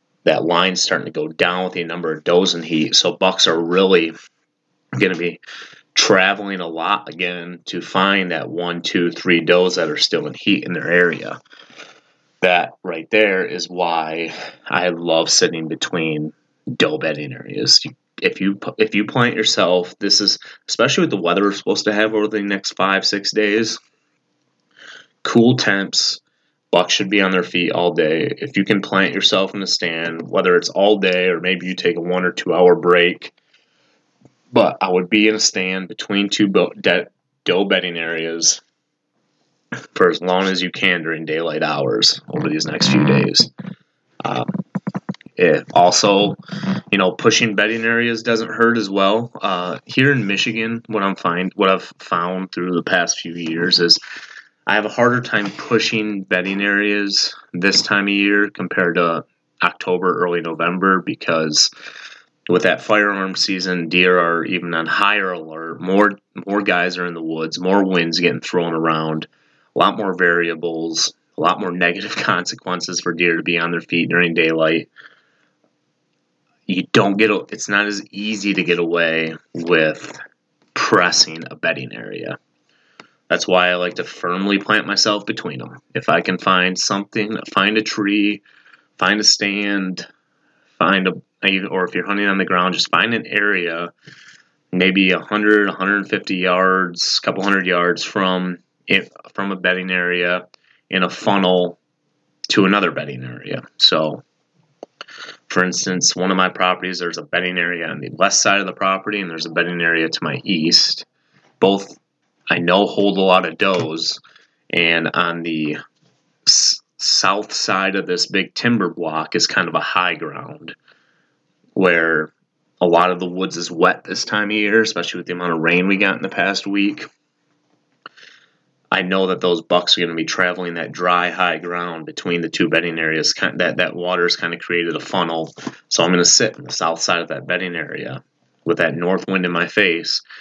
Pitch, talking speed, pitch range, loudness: 90 Hz, 175 wpm, 85-100 Hz, -17 LUFS